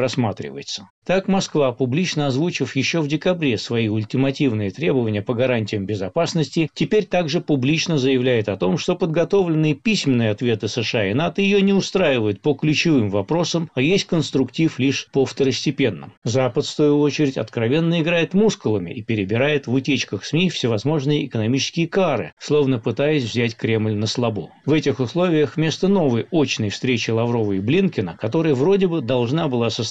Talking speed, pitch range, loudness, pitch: 155 wpm, 120-165 Hz, -20 LUFS, 140 Hz